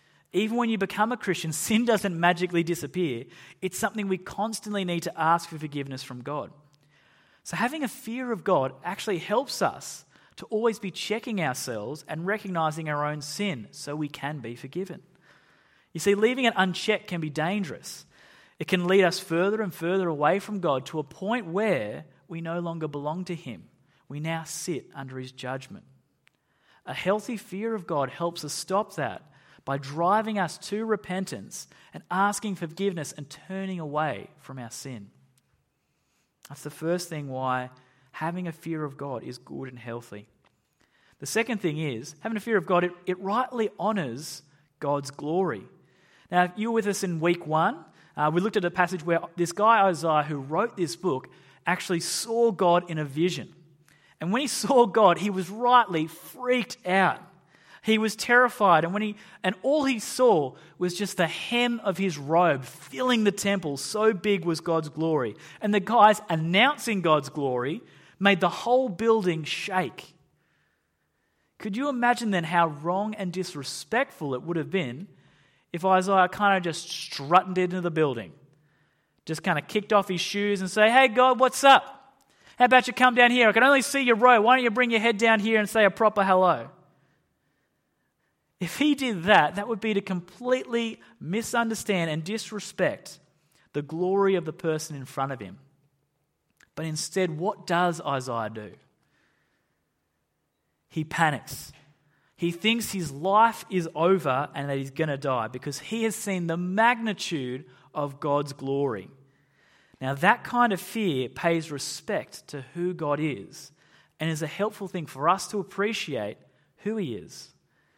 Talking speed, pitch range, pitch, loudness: 170 wpm, 150-210 Hz, 175 Hz, -26 LUFS